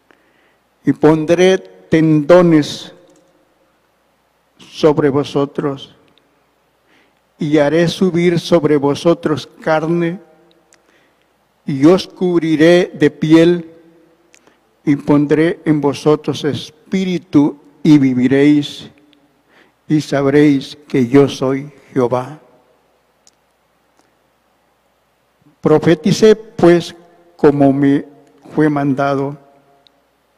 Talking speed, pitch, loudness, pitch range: 70 wpm, 150 Hz, -14 LUFS, 140-165 Hz